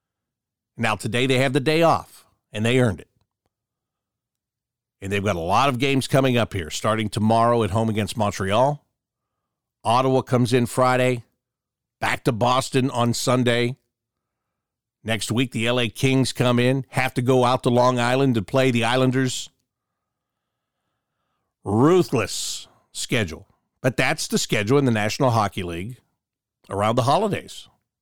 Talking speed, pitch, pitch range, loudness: 145 wpm, 125 Hz, 110-130 Hz, -21 LUFS